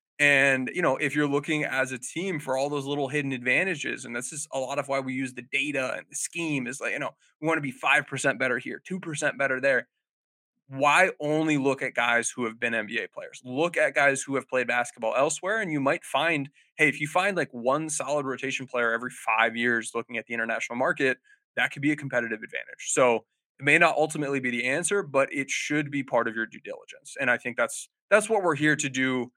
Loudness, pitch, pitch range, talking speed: -26 LUFS, 135 Hz, 125-150 Hz, 235 wpm